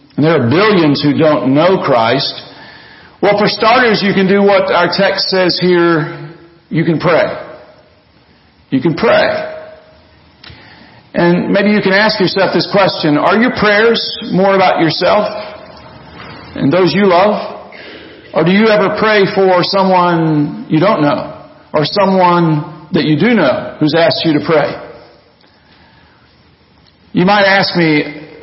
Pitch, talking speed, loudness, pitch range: 185 Hz, 140 wpm, -11 LUFS, 165-205 Hz